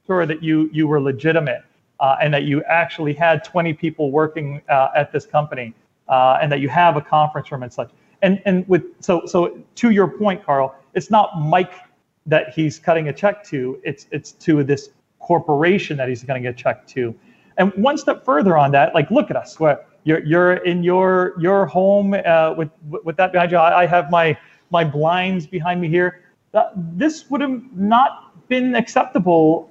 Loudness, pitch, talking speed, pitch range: -18 LUFS, 165 Hz, 190 wpm, 150-185 Hz